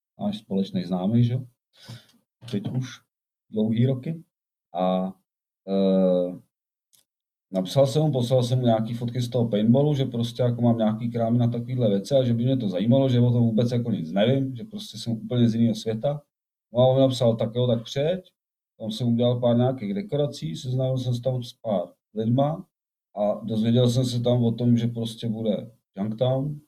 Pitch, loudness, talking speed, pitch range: 120 Hz, -24 LUFS, 180 wpm, 115-130 Hz